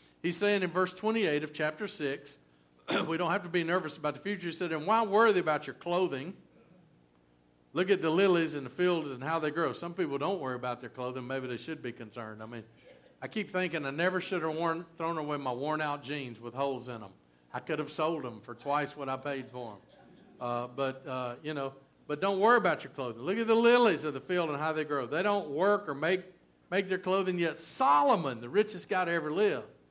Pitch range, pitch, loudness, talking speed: 130-185 Hz, 155 Hz, -31 LUFS, 235 wpm